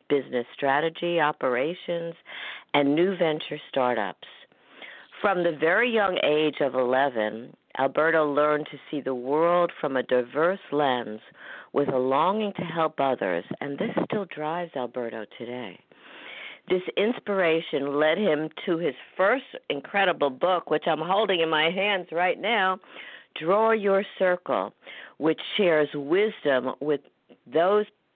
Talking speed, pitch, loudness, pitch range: 130 wpm, 155 Hz, -25 LUFS, 135-185 Hz